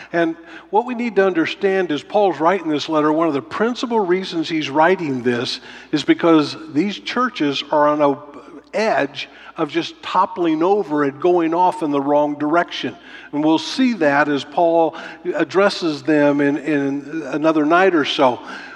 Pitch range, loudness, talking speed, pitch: 150-200 Hz, -18 LUFS, 165 wpm, 165 Hz